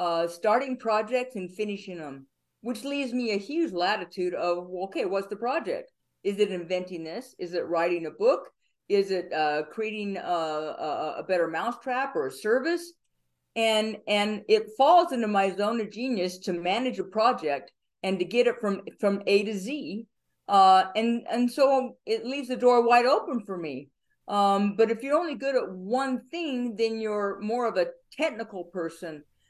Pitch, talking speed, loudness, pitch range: 215 Hz, 180 wpm, -27 LUFS, 185-250 Hz